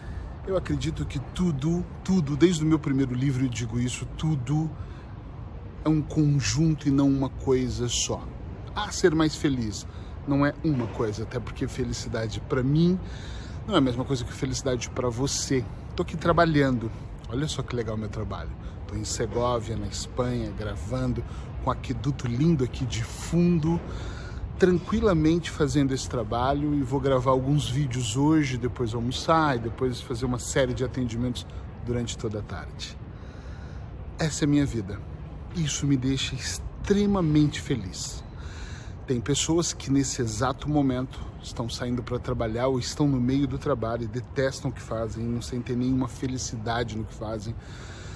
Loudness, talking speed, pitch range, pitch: -27 LUFS, 160 wpm, 115-145 Hz, 125 Hz